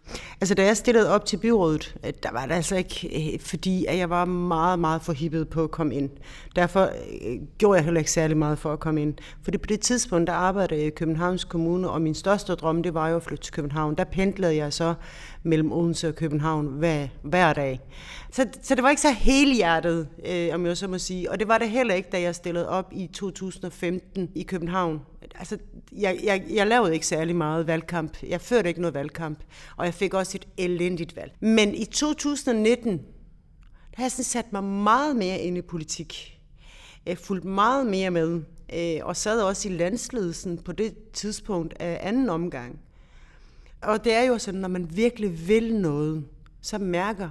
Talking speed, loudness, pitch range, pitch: 200 wpm, -25 LUFS, 165-200 Hz, 175 Hz